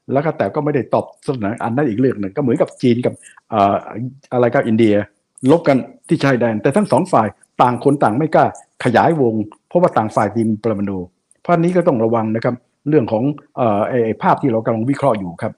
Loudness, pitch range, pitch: -17 LUFS, 110-140 Hz, 120 Hz